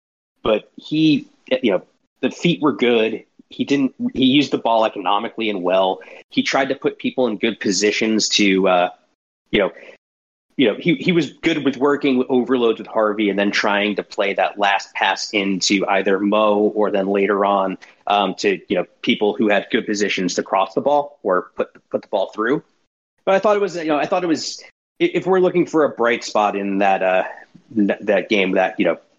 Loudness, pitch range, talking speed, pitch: -19 LUFS, 100-155 Hz, 210 wpm, 115 Hz